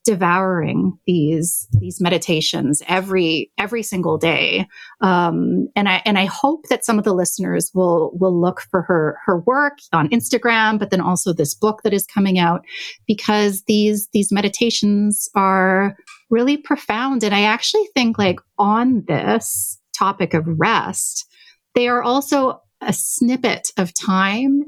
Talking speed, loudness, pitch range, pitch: 150 wpm, -18 LUFS, 180-235 Hz, 200 Hz